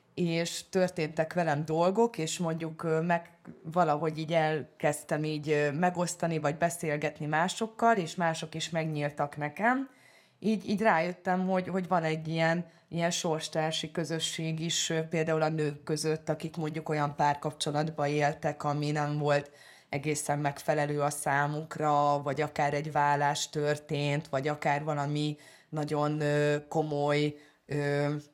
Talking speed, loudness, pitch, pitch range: 125 wpm, -30 LUFS, 155 Hz, 145-165 Hz